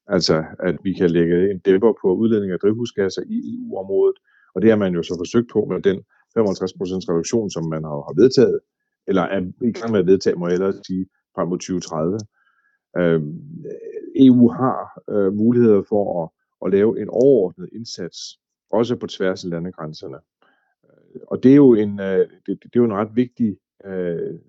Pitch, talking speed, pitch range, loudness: 100 Hz, 170 wpm, 90-120 Hz, -19 LUFS